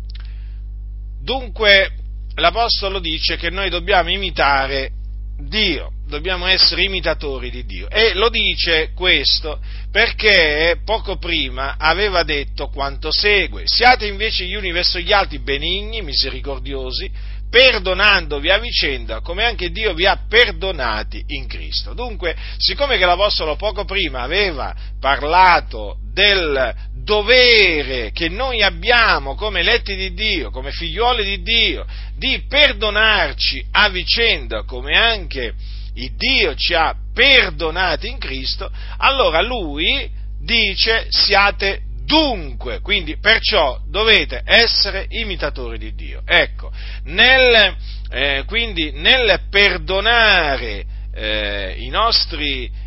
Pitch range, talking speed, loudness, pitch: 130-210 Hz, 110 wpm, -15 LUFS, 175 Hz